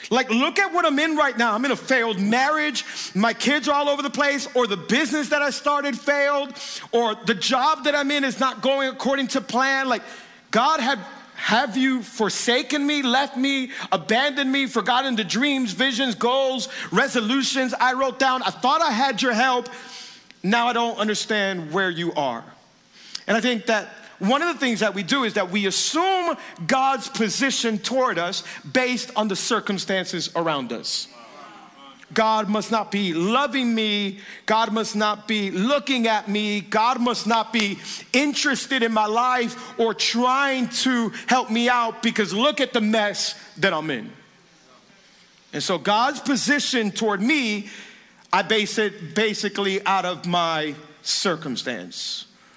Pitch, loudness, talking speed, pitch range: 235 Hz, -22 LUFS, 165 wpm, 210-270 Hz